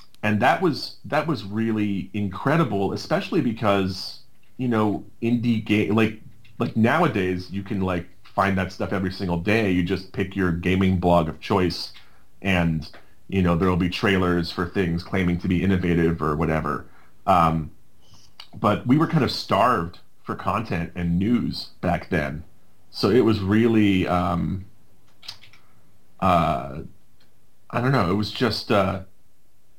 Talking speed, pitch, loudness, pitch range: 150 wpm, 95 Hz, -23 LUFS, 90-110 Hz